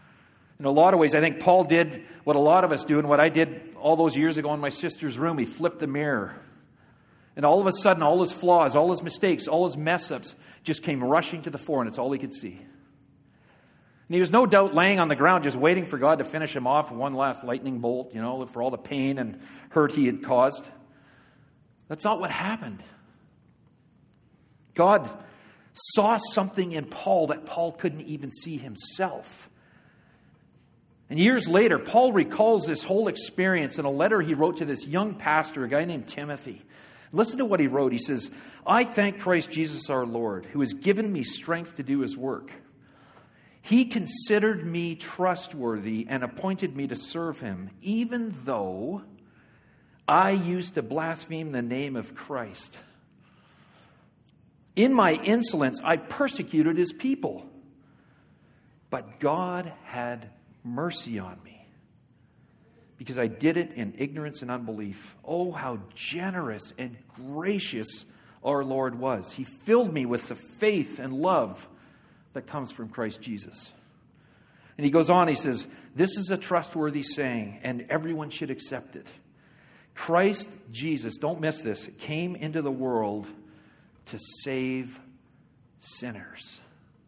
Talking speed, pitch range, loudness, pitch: 165 wpm, 130-180 Hz, -26 LUFS, 155 Hz